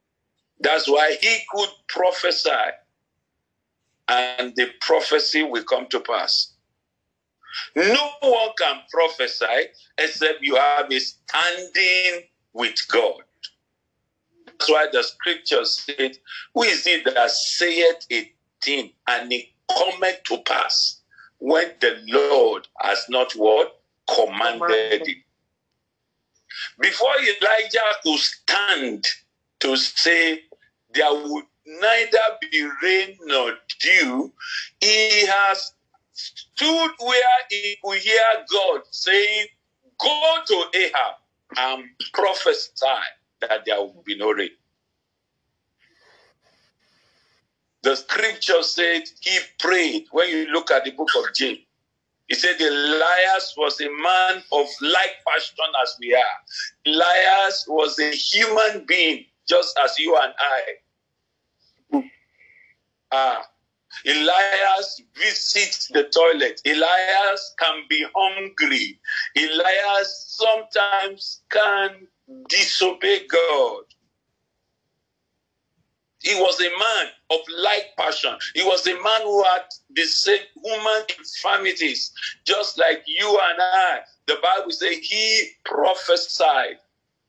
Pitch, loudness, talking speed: 200 Hz, -20 LUFS, 110 wpm